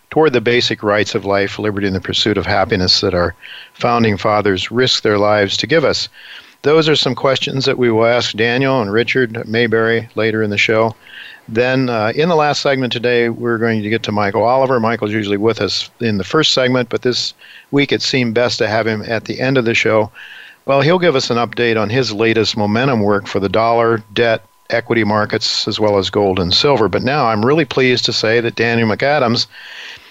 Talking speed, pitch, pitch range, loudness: 215 wpm, 115 Hz, 105-125 Hz, -15 LUFS